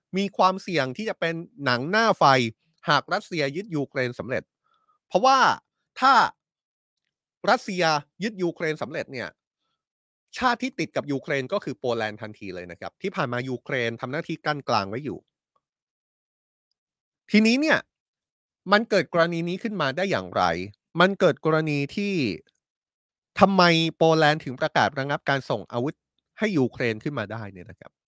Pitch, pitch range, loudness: 155 Hz, 130-190 Hz, -24 LUFS